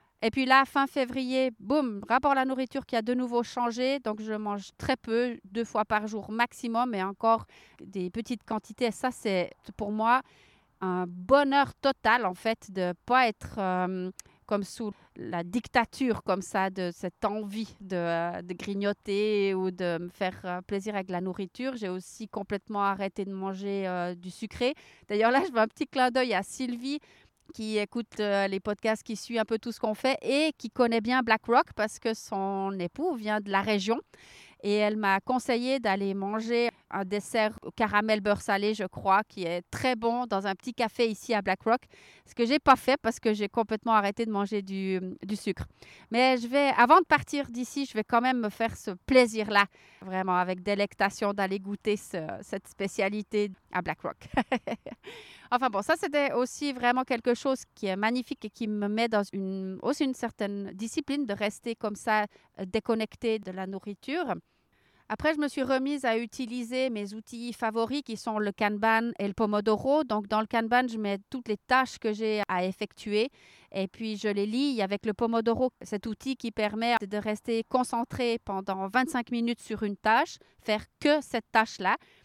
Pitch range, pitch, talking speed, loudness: 200-245 Hz, 220 Hz, 190 wpm, -29 LUFS